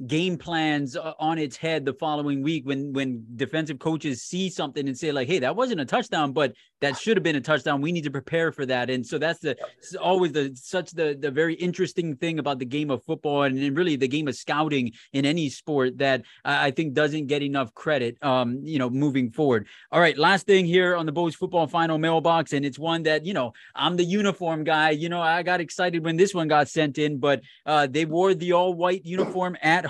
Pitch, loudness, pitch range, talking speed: 155 Hz, -24 LUFS, 140-170 Hz, 235 wpm